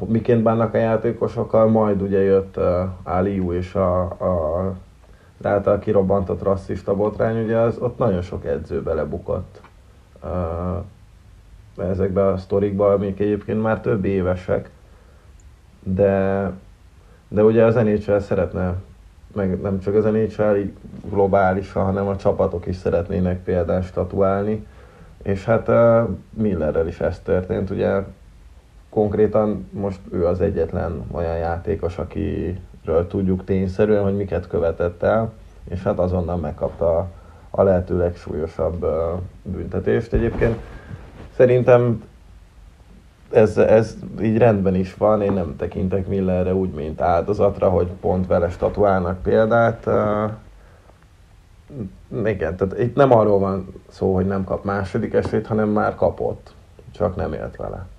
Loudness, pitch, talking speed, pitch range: -20 LUFS, 95 Hz, 125 wpm, 90-105 Hz